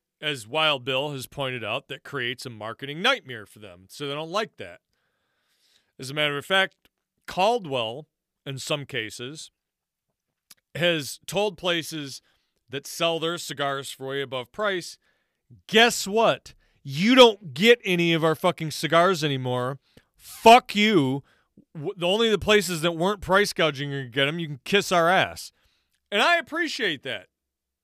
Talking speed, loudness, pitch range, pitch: 150 wpm, -23 LUFS, 135-190 Hz, 155 Hz